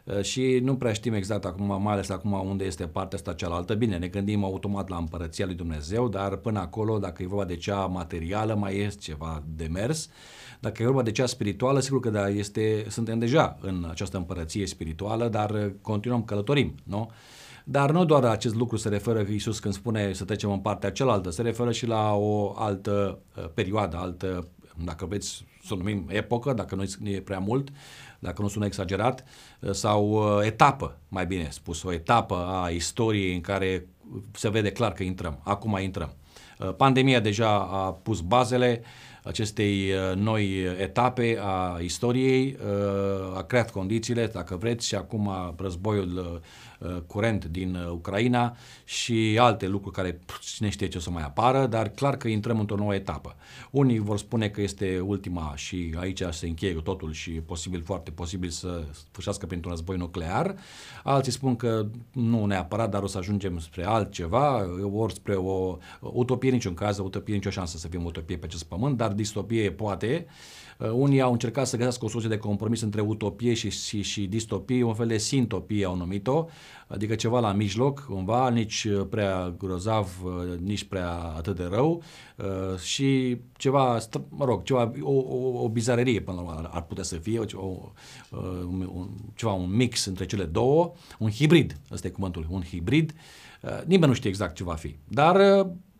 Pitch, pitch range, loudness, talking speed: 100 Hz, 95-120 Hz, -27 LUFS, 180 wpm